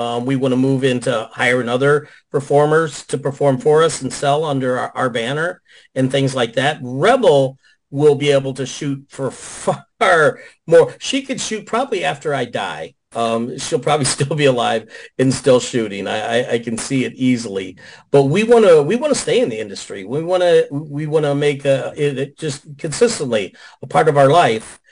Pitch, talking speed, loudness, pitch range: 140 Hz, 200 wpm, -17 LUFS, 130-155 Hz